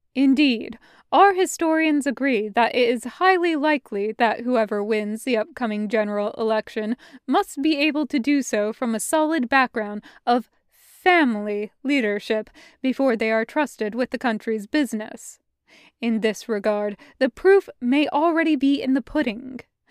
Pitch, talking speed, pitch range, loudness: 250 Hz, 145 wpm, 220-295 Hz, -22 LUFS